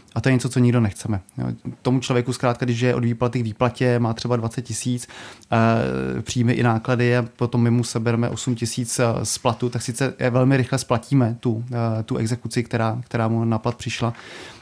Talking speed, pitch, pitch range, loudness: 190 wpm, 120 Hz, 115-125 Hz, -22 LUFS